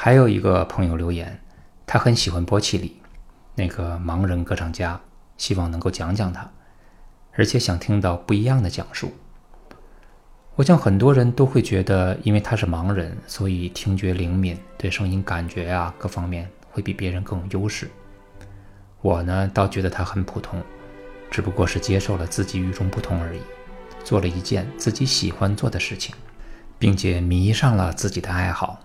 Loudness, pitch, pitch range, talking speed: -22 LUFS, 95 Hz, 90-105 Hz, 260 characters per minute